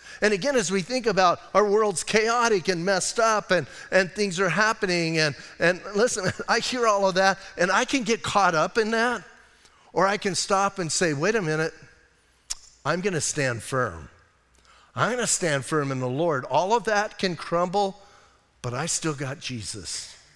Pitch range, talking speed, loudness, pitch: 155-210 Hz, 185 wpm, -24 LUFS, 190 Hz